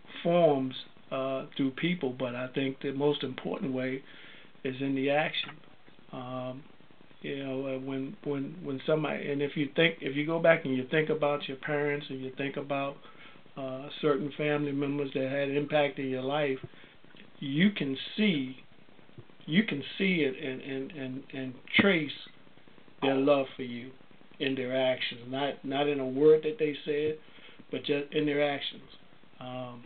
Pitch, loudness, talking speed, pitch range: 140 Hz, -30 LUFS, 170 wpm, 135-150 Hz